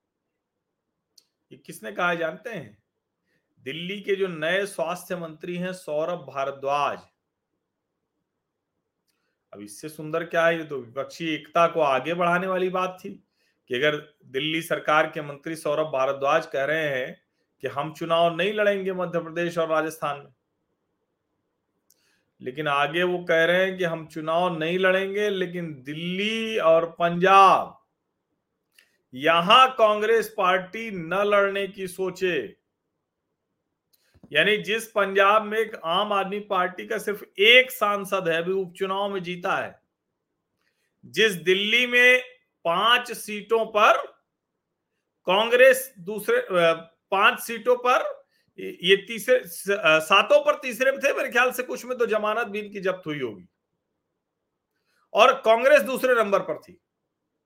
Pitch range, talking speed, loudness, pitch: 165-215 Hz, 130 wpm, -22 LUFS, 185 Hz